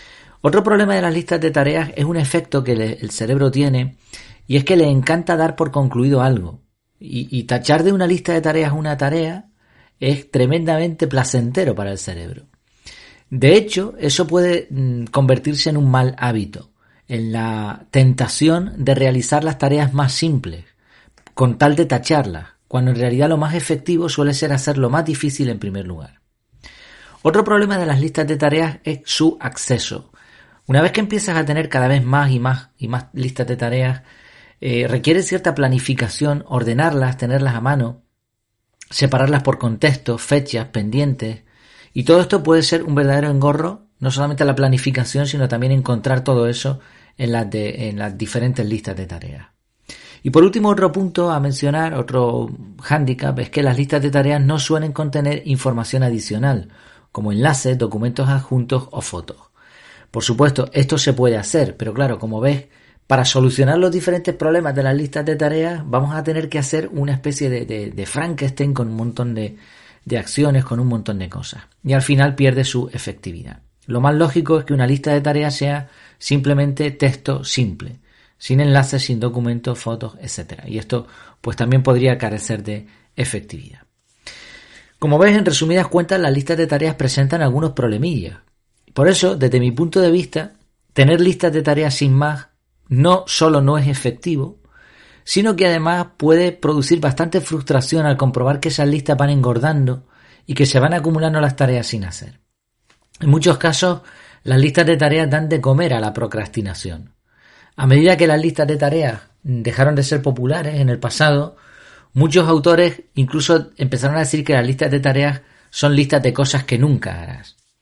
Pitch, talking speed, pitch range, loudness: 140 Hz, 175 wpm, 125-155 Hz, -17 LUFS